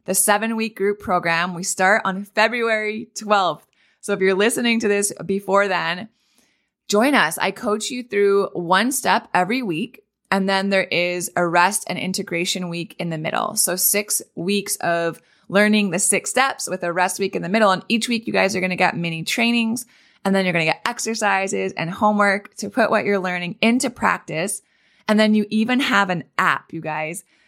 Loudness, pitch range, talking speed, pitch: -20 LUFS, 180-220 Hz, 200 wpm, 200 Hz